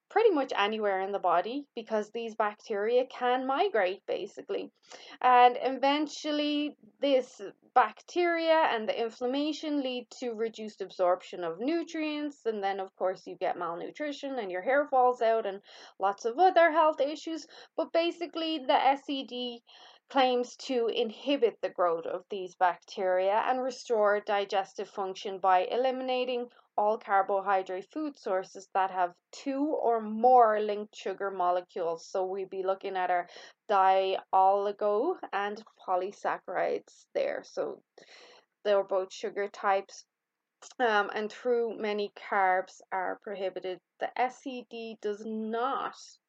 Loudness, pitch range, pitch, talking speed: -30 LUFS, 195-265 Hz, 225 Hz, 130 wpm